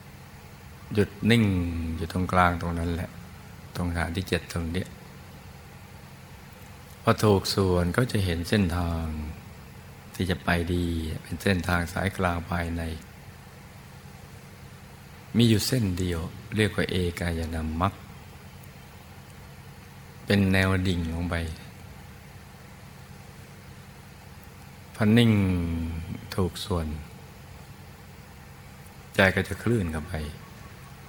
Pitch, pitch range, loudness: 90 Hz, 85-100 Hz, -26 LUFS